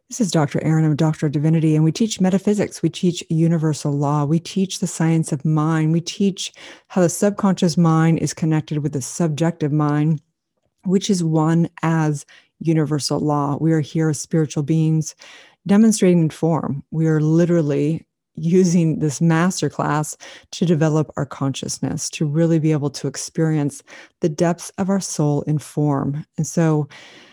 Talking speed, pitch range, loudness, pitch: 160 wpm, 150-170 Hz, -19 LUFS, 160 Hz